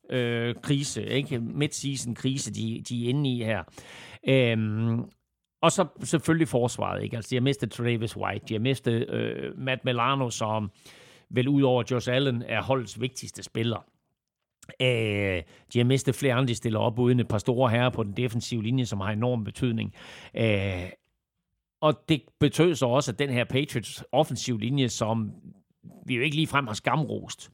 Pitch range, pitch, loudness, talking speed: 110-135 Hz, 125 Hz, -27 LUFS, 170 wpm